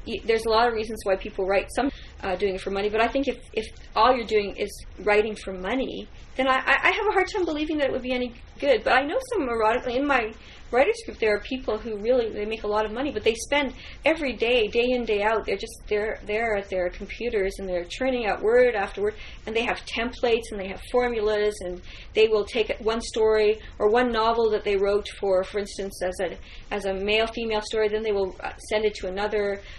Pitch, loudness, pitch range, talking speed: 220 Hz, -25 LUFS, 205-255 Hz, 245 wpm